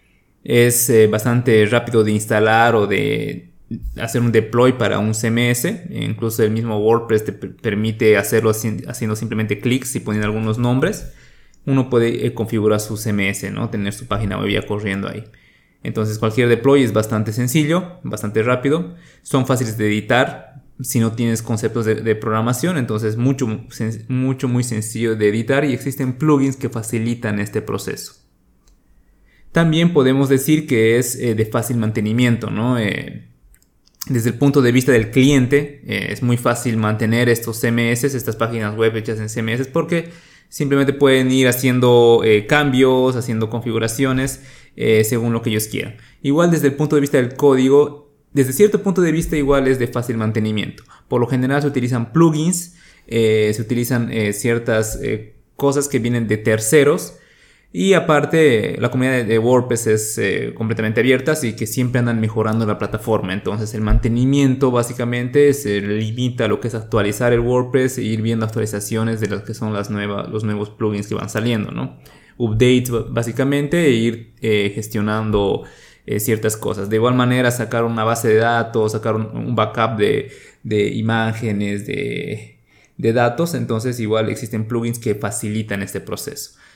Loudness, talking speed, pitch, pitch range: -18 LUFS, 155 wpm, 115 Hz, 110-130 Hz